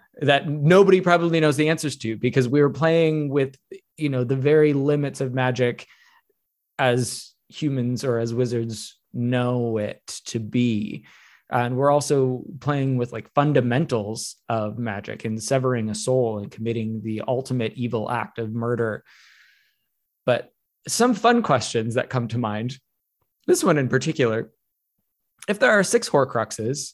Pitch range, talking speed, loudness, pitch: 115-145 Hz, 145 wpm, -22 LUFS, 125 Hz